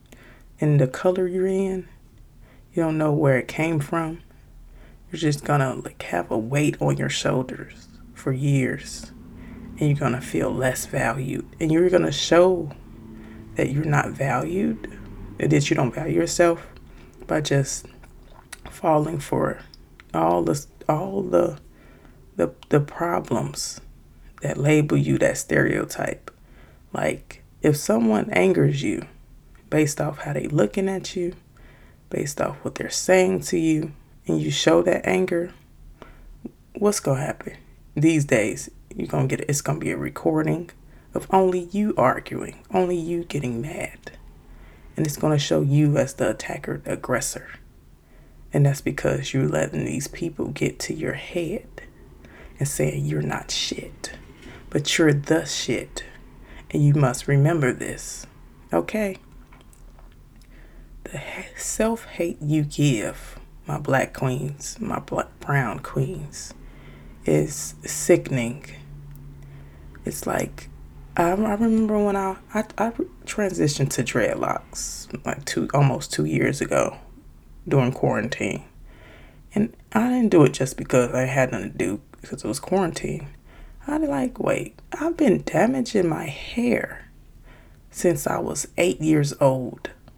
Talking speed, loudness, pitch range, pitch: 135 wpm, -23 LUFS, 120-175 Hz, 145 Hz